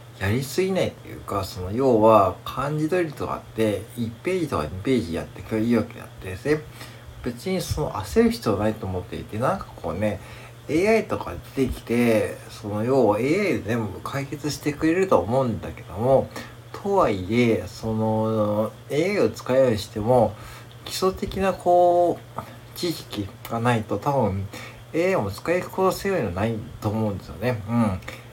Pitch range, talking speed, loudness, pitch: 110-135 Hz, 320 characters per minute, -24 LUFS, 115 Hz